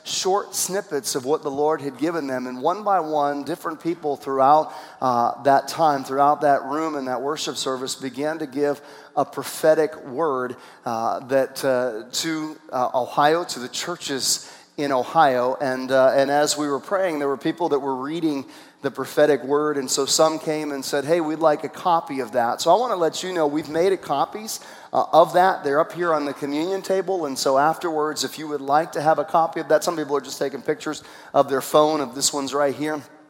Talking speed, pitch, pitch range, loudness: 215 wpm, 150 Hz, 135-160 Hz, -22 LUFS